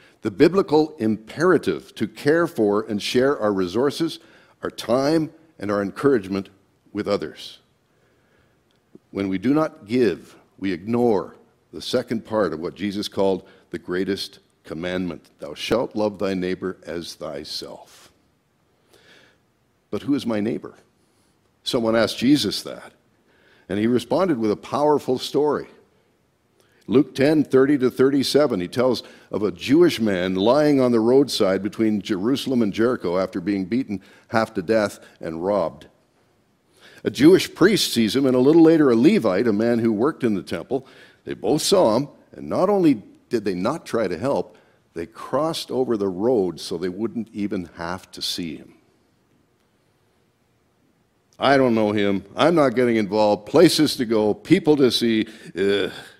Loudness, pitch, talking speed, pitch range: -21 LUFS, 110 Hz, 155 wpm, 100-135 Hz